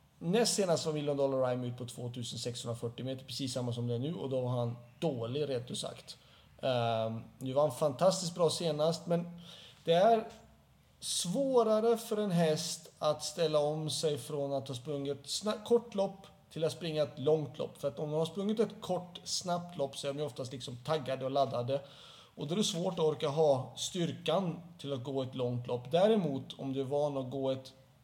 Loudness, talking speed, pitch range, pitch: -34 LUFS, 210 wpm, 130-170 Hz, 150 Hz